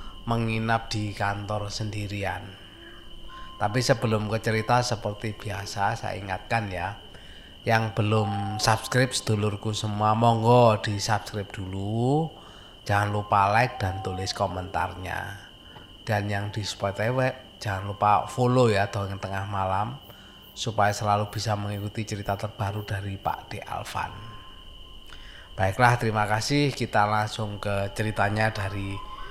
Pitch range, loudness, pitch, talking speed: 100-110 Hz, -26 LUFS, 105 Hz, 115 wpm